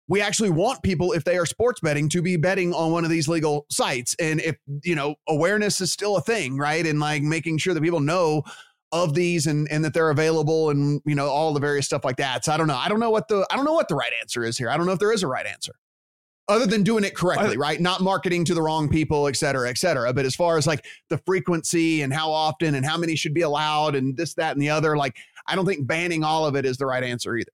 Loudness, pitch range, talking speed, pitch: -23 LUFS, 145-175 Hz, 280 wpm, 160 Hz